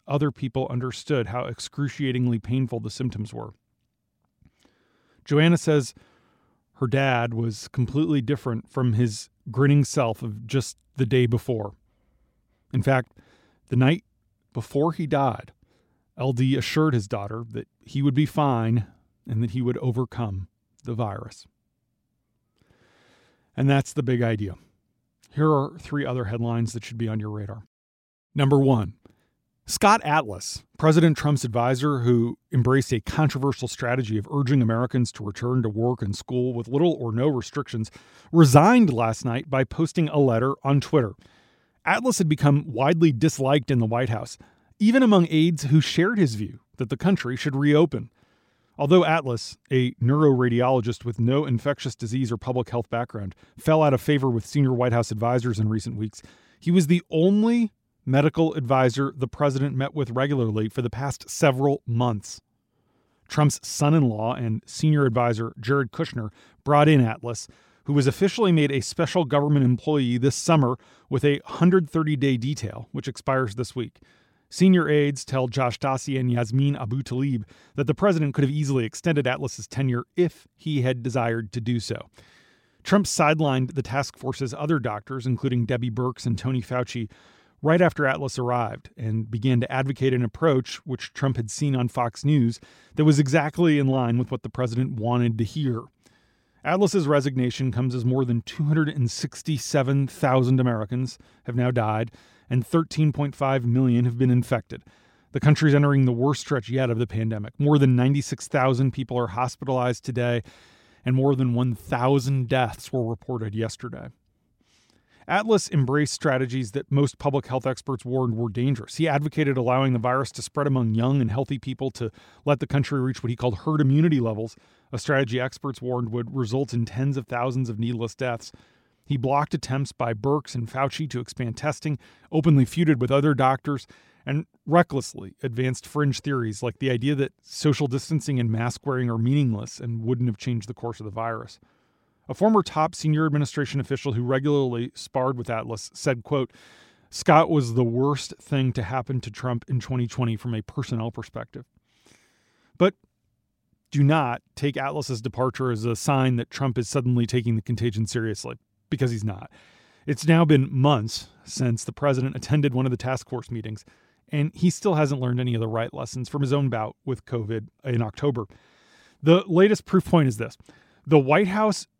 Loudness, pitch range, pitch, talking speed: -24 LUFS, 120-145 Hz, 130 Hz, 165 wpm